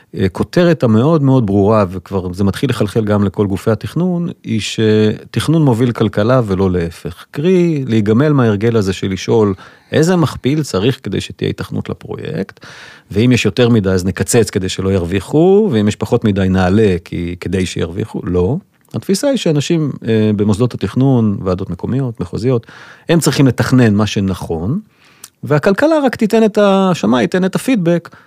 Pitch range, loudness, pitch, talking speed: 100-155 Hz, -14 LUFS, 115 Hz, 150 wpm